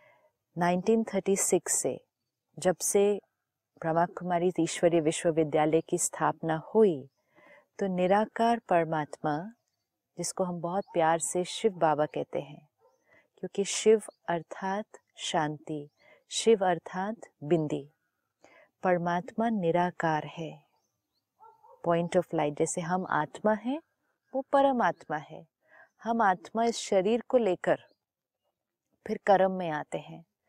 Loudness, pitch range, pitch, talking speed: -29 LUFS, 165-215 Hz, 180 Hz, 105 wpm